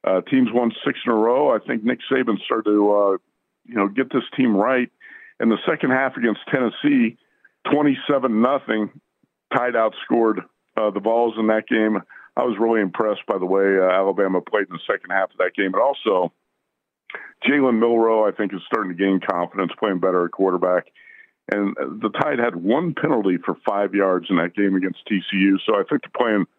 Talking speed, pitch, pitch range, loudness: 195 wpm, 105 Hz, 95-125 Hz, -20 LUFS